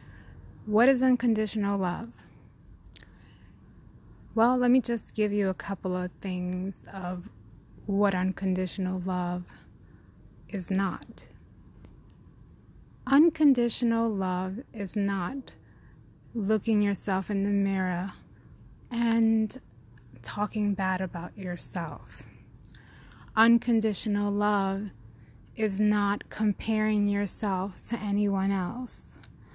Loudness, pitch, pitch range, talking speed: -28 LUFS, 195 Hz, 175-215 Hz, 85 wpm